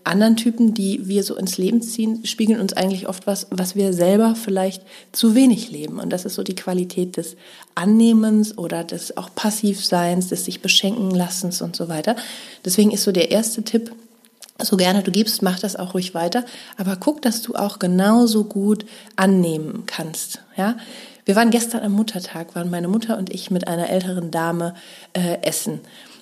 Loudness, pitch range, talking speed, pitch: -20 LUFS, 185-225 Hz, 185 wpm, 200 Hz